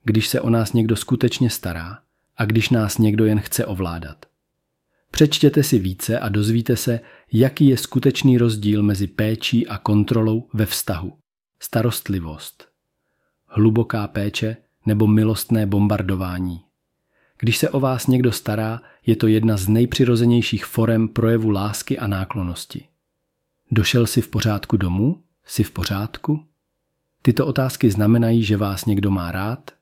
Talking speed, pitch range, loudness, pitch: 135 wpm, 105-125 Hz, -20 LUFS, 115 Hz